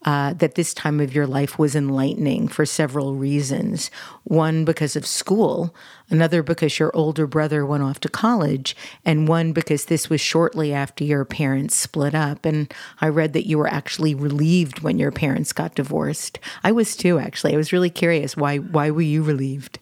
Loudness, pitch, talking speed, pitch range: -21 LUFS, 155 Hz, 190 wpm, 145-165 Hz